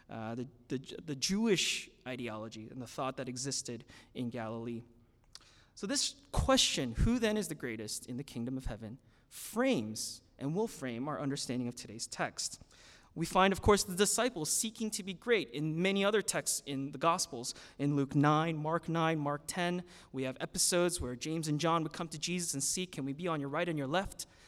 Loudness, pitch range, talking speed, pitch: -34 LUFS, 120-175 Hz, 200 wpm, 140 Hz